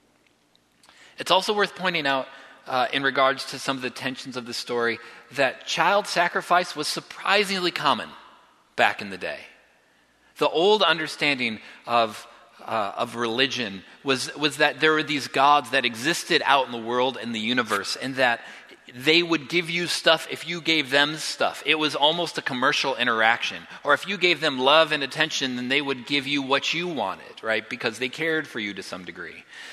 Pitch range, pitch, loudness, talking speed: 125-165 Hz, 145 Hz, -23 LUFS, 185 wpm